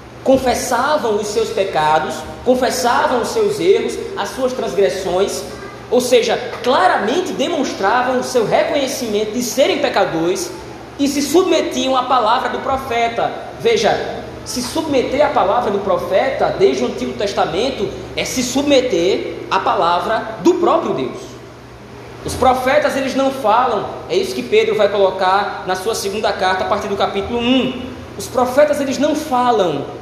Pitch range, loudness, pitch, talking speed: 210-300 Hz, -16 LUFS, 255 Hz, 145 wpm